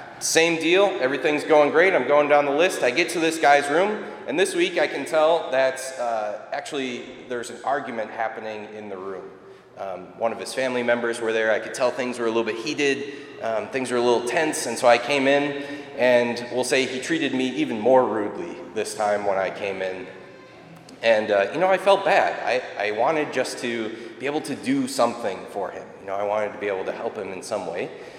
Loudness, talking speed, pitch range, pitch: -23 LUFS, 230 wpm, 115-155 Hz, 130 Hz